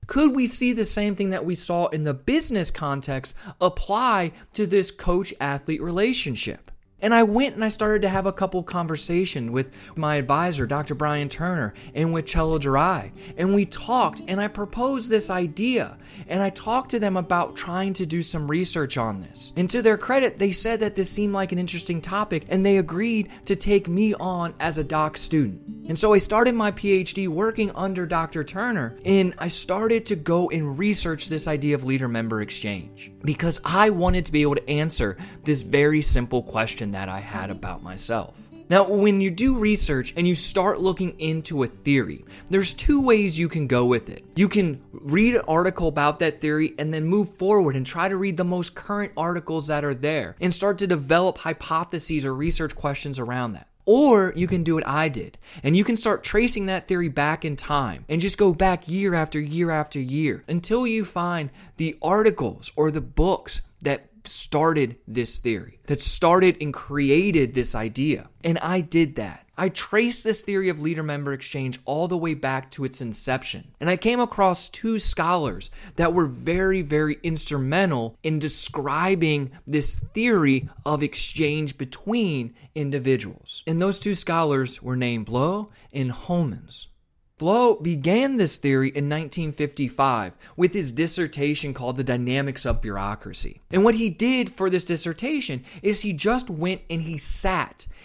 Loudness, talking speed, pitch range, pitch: -23 LUFS, 180 wpm, 145-195 Hz, 165 Hz